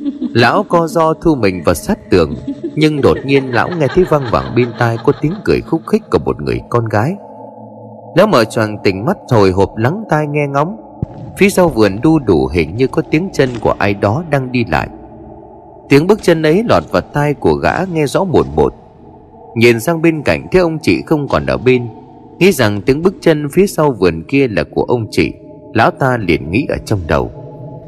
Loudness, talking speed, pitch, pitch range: -13 LUFS, 215 wpm, 140 Hz, 110-165 Hz